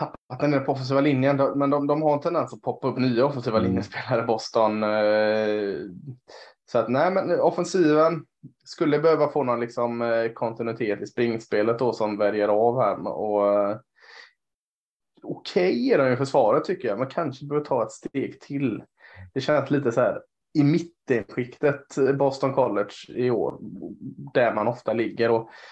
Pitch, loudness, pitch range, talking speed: 130 Hz, -24 LUFS, 110-145 Hz, 165 wpm